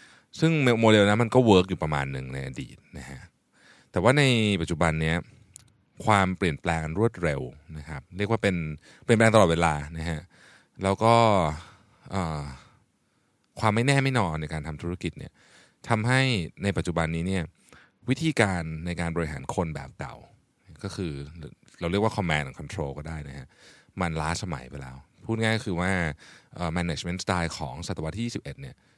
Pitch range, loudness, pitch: 80-110 Hz, -26 LUFS, 90 Hz